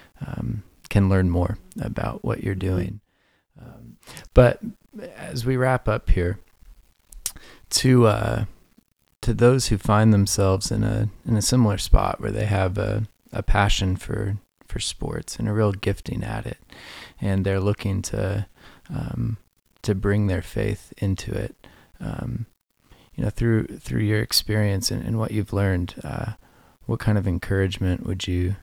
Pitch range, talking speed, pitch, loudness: 95-115 Hz, 155 wpm, 105 Hz, -24 LUFS